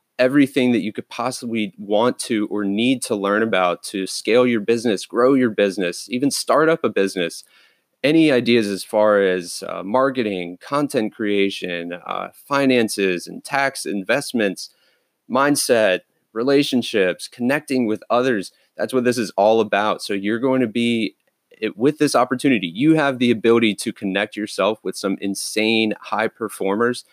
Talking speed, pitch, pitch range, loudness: 155 wpm, 115 Hz, 100-130 Hz, -20 LUFS